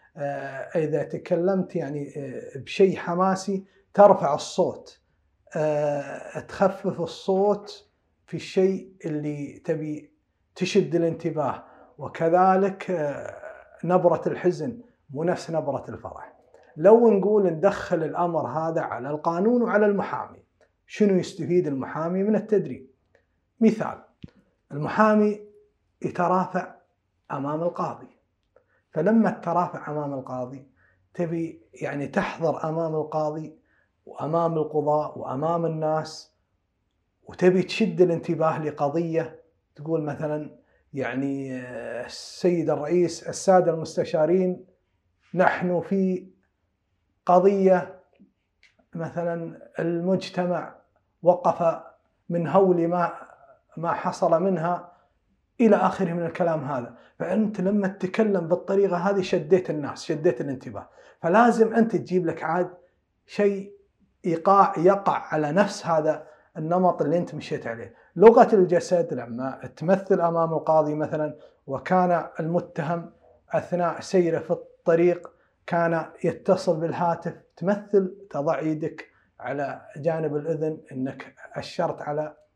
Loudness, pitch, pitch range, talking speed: -24 LUFS, 170 Hz, 155-190 Hz, 100 wpm